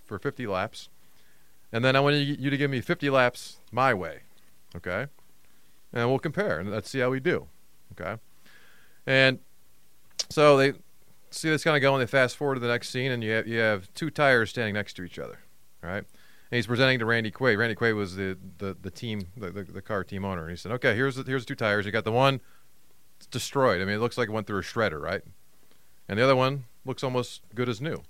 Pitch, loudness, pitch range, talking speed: 120 Hz, -26 LUFS, 100-135 Hz, 235 wpm